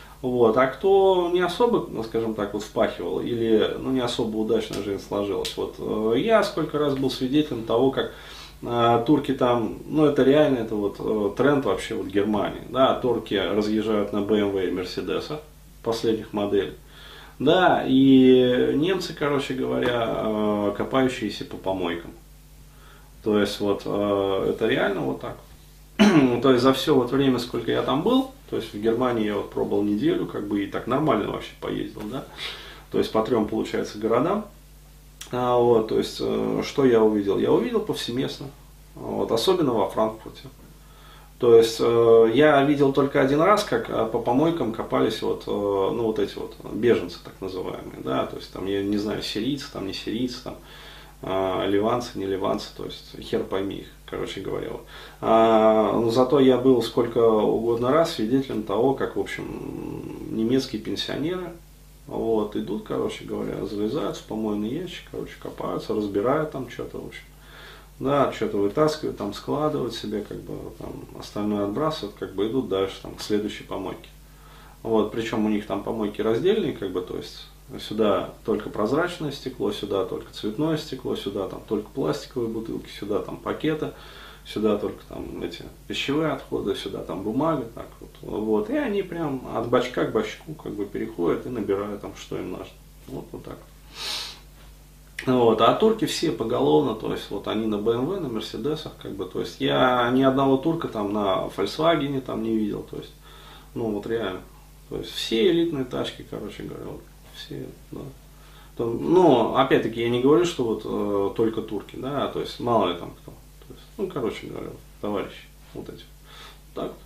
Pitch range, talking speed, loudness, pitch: 105-135 Hz, 170 wpm, -24 LUFS, 115 Hz